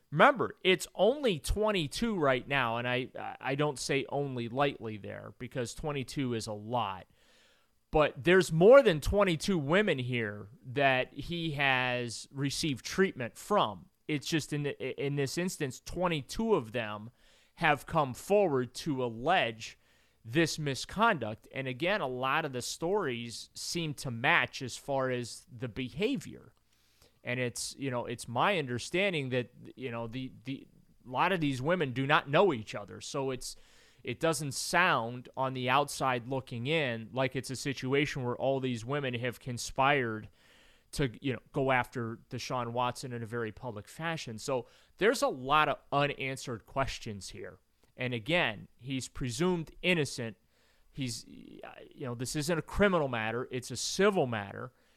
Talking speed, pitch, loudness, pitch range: 155 wpm, 130 Hz, -31 LUFS, 120-150 Hz